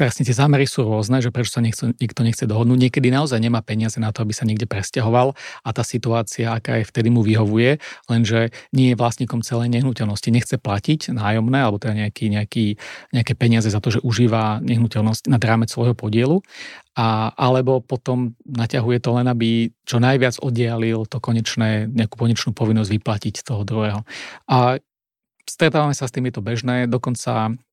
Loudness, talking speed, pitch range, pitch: -19 LUFS, 170 wpm, 110-125 Hz, 120 Hz